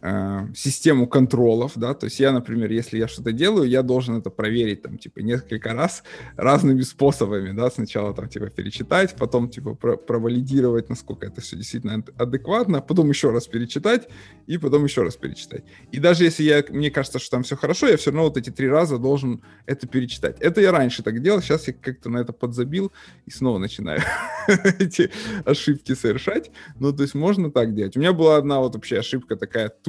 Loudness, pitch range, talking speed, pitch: -21 LUFS, 115-145 Hz, 190 wpm, 130 Hz